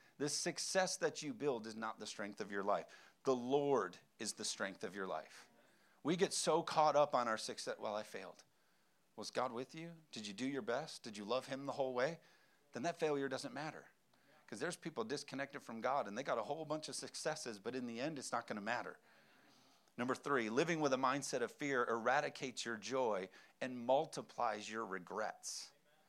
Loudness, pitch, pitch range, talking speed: -41 LUFS, 135 Hz, 120-155 Hz, 205 wpm